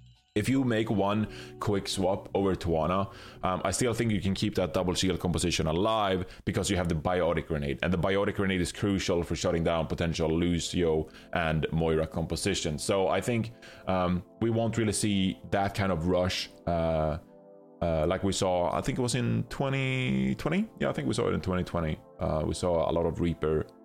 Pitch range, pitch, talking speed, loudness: 85-100 Hz, 90 Hz, 195 wpm, -29 LUFS